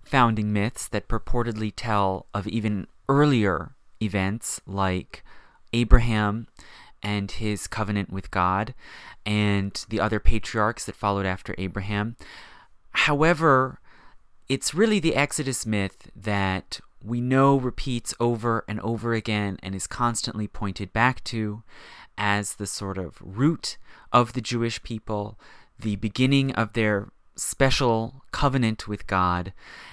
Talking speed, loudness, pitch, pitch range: 120 wpm, -25 LUFS, 110 Hz, 100-120 Hz